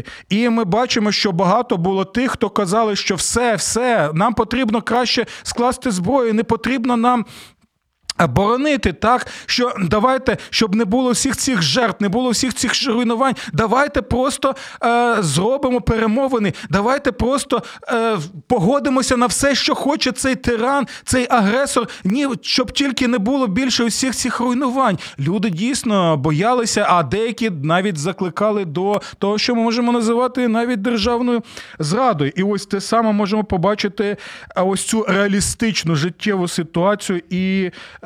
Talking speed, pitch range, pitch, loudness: 140 wpm, 200-250 Hz, 230 Hz, -17 LUFS